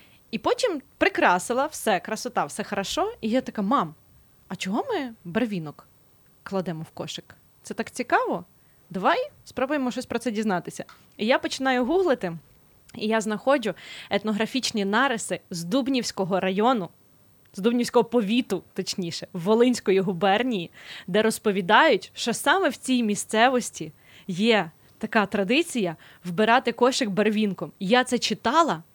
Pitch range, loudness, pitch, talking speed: 185-250 Hz, -24 LUFS, 220 Hz, 125 wpm